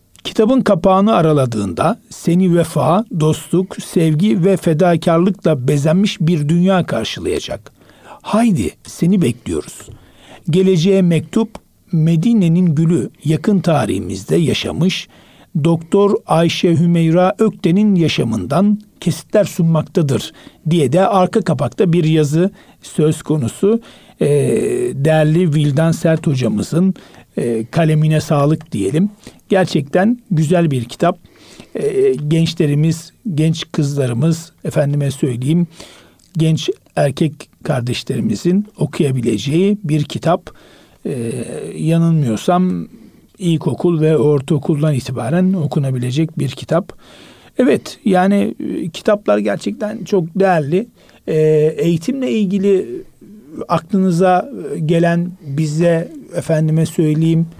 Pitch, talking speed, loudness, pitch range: 170 Hz, 85 wpm, -15 LUFS, 155-190 Hz